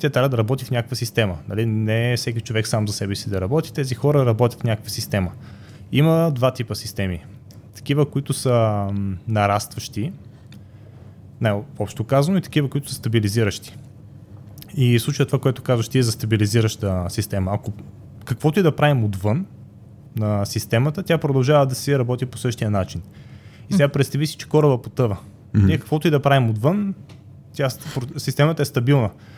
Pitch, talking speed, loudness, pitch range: 120 Hz, 170 wpm, -21 LUFS, 105-140 Hz